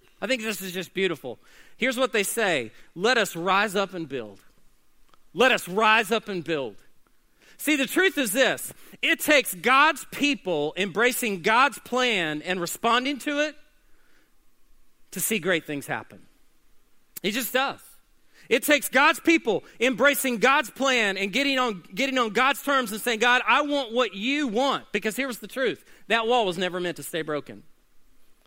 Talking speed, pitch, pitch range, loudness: 170 wpm, 235 Hz, 190-270 Hz, -24 LUFS